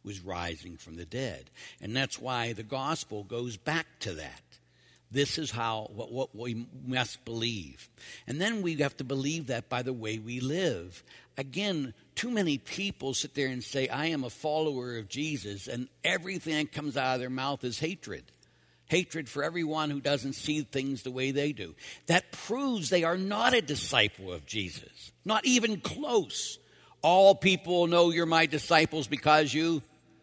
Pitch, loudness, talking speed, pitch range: 140 Hz, -30 LUFS, 175 wpm, 115-160 Hz